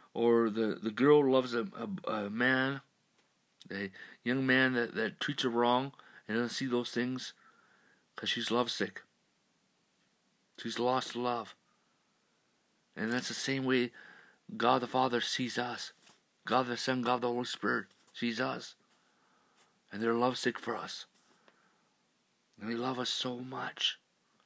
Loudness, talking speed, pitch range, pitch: -33 LUFS, 140 wpm, 115-130 Hz, 120 Hz